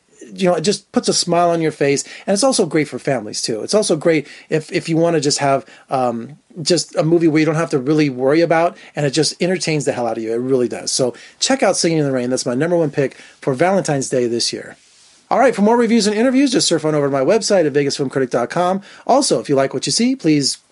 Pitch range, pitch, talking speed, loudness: 135-180 Hz, 155 Hz, 265 wpm, -17 LUFS